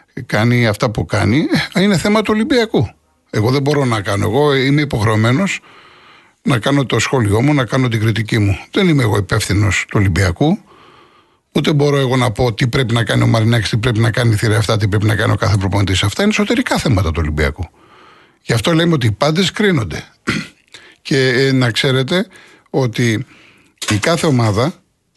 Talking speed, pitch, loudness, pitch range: 180 wpm, 125 Hz, -15 LUFS, 110-150 Hz